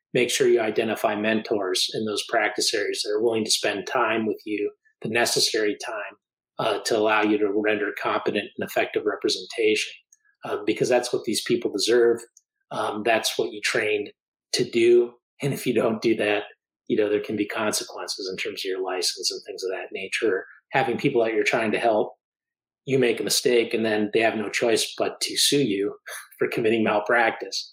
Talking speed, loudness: 195 wpm, -24 LUFS